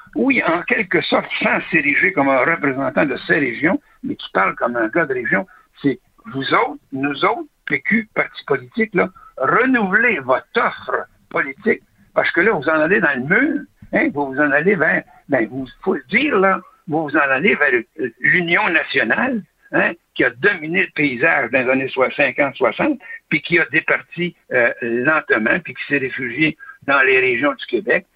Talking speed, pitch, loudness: 185 wpm, 170 Hz, -17 LUFS